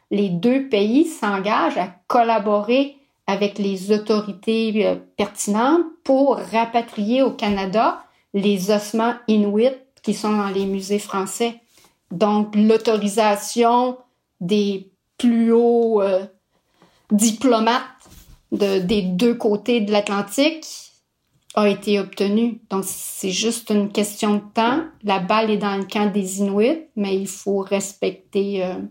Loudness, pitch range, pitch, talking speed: -20 LUFS, 200-235 Hz, 210 Hz, 120 wpm